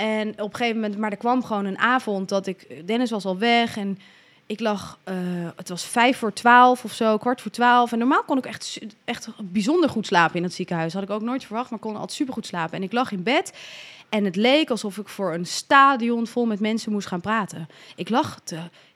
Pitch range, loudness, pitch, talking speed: 195-240 Hz, -22 LUFS, 215 Hz, 235 wpm